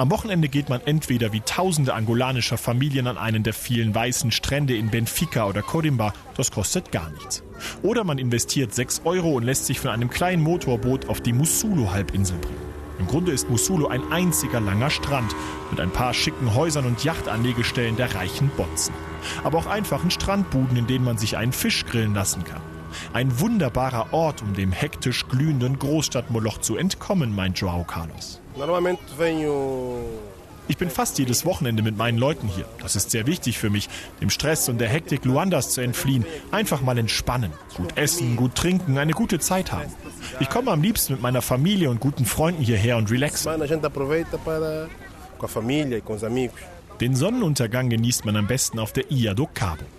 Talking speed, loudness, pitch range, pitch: 165 wpm, -23 LUFS, 110-150 Hz, 125 Hz